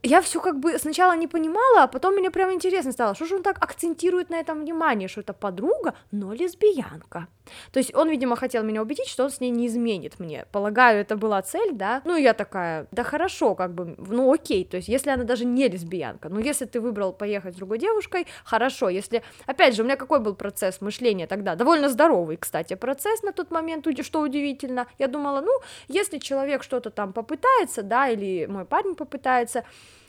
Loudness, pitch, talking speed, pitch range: -24 LUFS, 260 Hz, 205 wpm, 215-330 Hz